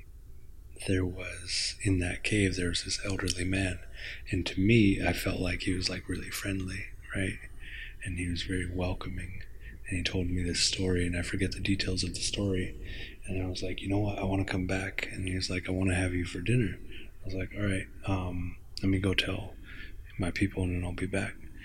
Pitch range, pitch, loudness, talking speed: 90-95 Hz, 95 Hz, -32 LUFS, 220 wpm